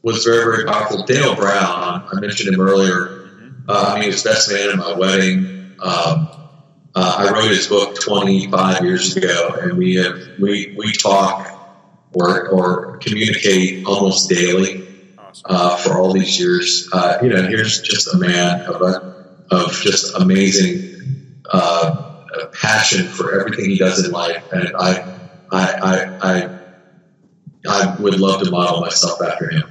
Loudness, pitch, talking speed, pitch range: -15 LUFS, 95 Hz, 160 wpm, 90-105 Hz